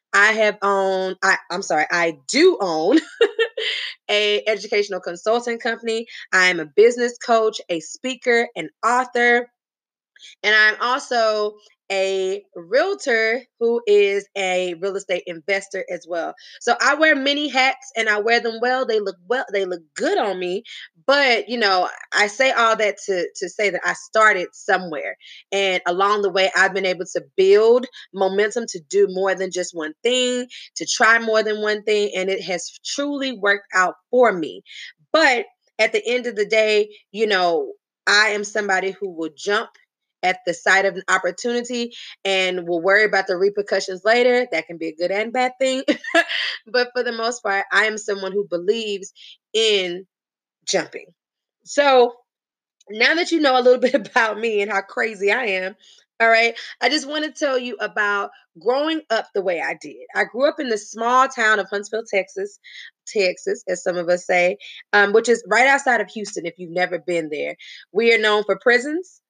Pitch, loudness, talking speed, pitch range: 215 Hz, -19 LUFS, 180 wpm, 195-250 Hz